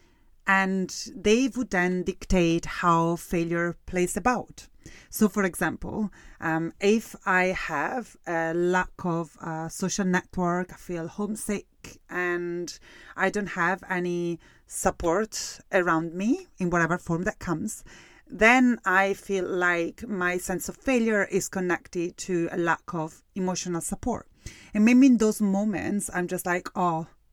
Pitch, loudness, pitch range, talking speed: 180 Hz, -26 LUFS, 170-200 Hz, 140 wpm